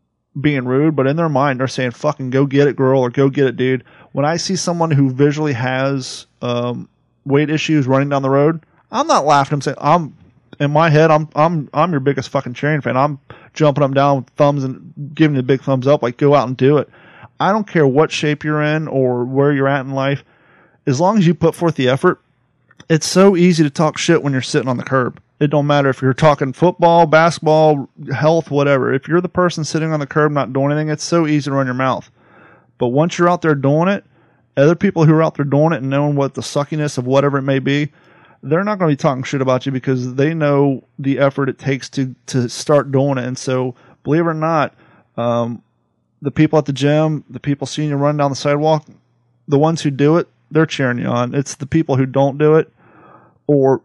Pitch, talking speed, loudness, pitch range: 145 Hz, 235 wpm, -16 LUFS, 135-155 Hz